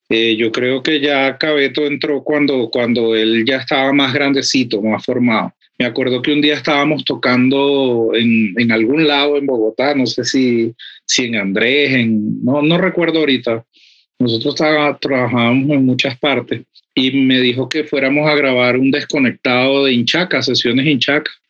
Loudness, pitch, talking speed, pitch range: -14 LUFS, 135 Hz, 165 wpm, 120-145 Hz